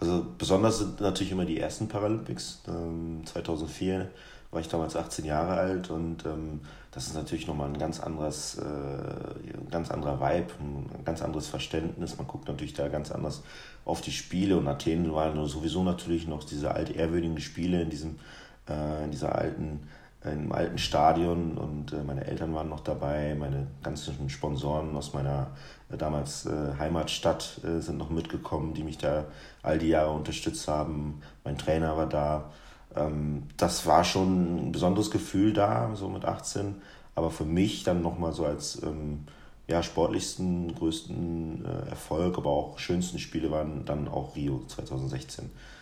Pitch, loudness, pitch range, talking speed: 80 Hz, -31 LUFS, 75-85 Hz, 150 wpm